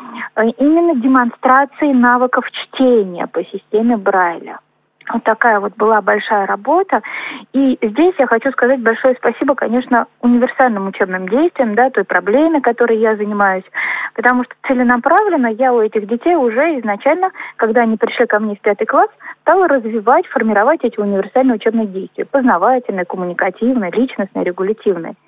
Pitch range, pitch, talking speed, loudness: 215-270 Hz, 240 Hz, 140 wpm, -14 LUFS